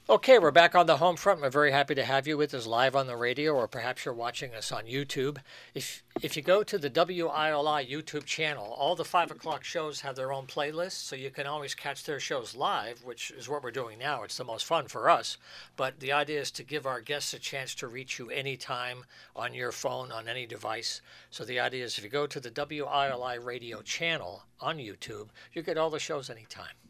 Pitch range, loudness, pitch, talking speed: 130-150 Hz, -30 LUFS, 140 Hz, 230 wpm